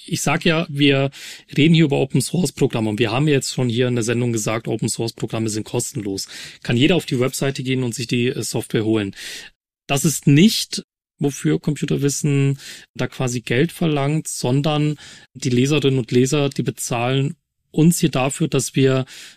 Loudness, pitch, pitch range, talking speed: -19 LUFS, 135 Hz, 120-150 Hz, 165 wpm